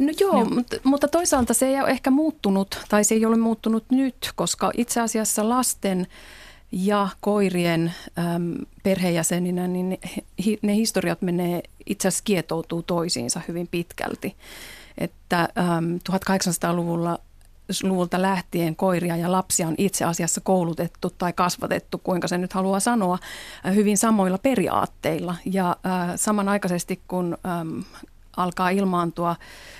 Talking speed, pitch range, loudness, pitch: 115 wpm, 175-210 Hz, -23 LUFS, 185 Hz